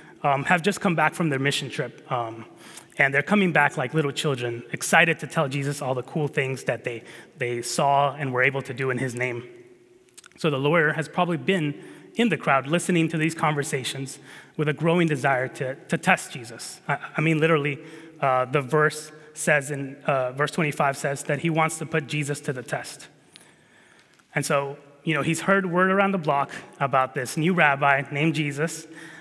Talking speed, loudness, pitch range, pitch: 195 wpm, -24 LUFS, 140-165 Hz, 150 Hz